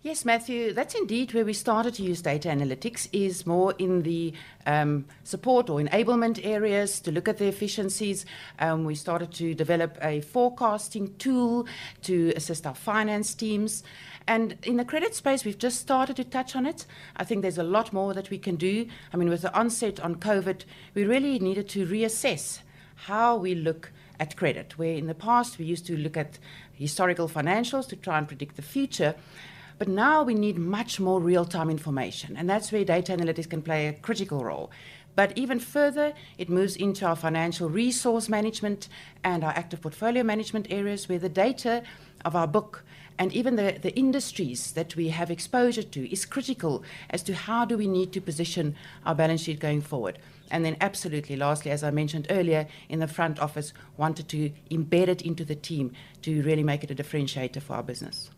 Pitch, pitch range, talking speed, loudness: 180 Hz, 155-215 Hz, 190 wpm, -28 LUFS